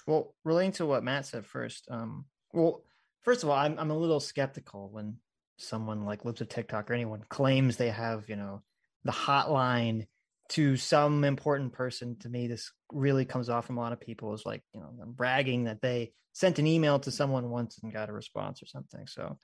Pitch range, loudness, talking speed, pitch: 115-140 Hz, -31 LUFS, 210 wpm, 125 Hz